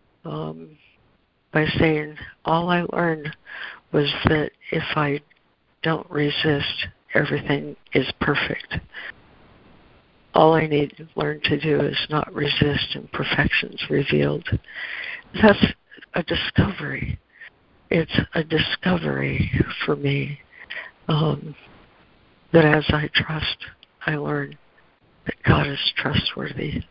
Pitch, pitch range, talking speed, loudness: 150 Hz, 140-155 Hz, 105 wpm, -22 LUFS